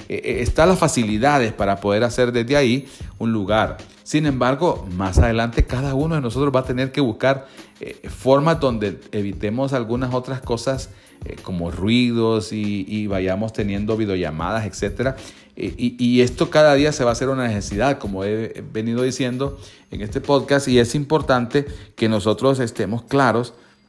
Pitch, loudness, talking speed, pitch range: 120 Hz, -20 LUFS, 165 wpm, 105-135 Hz